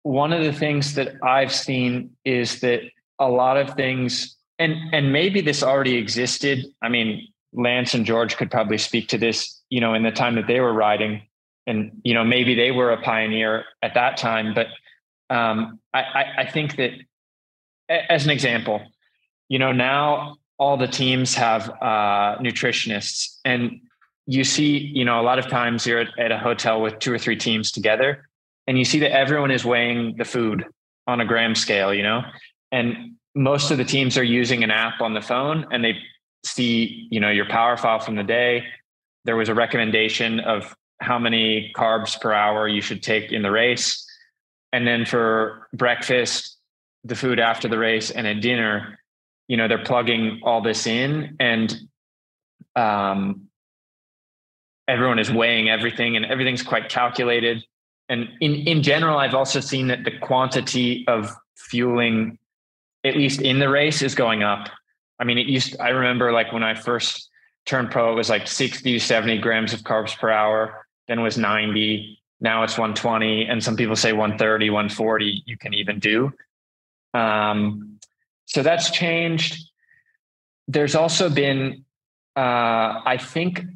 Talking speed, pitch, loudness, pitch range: 170 wpm, 120 Hz, -21 LUFS, 110-130 Hz